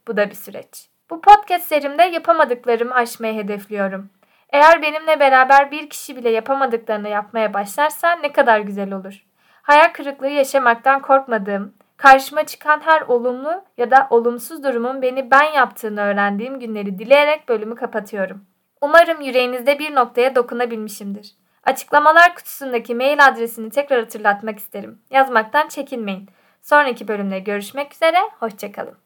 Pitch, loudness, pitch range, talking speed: 250 Hz, -16 LUFS, 215-290 Hz, 130 wpm